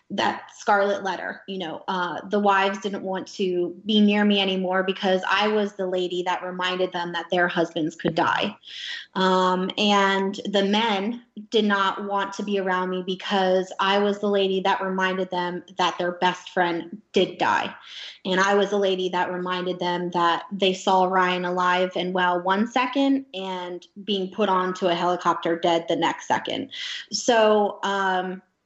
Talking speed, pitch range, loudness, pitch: 170 wpm, 180-200 Hz, -23 LUFS, 190 Hz